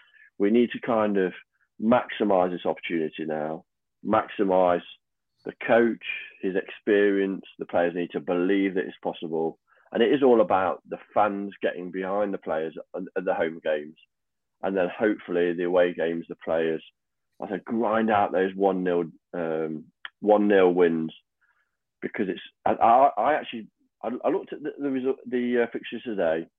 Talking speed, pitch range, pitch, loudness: 150 wpm, 85-105 Hz, 90 Hz, -25 LUFS